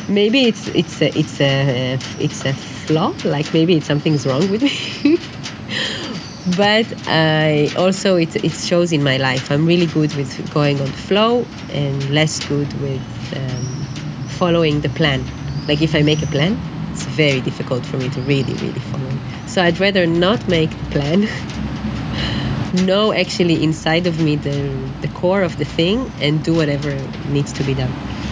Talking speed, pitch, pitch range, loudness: 170 wpm, 155 Hz, 140-175 Hz, -18 LUFS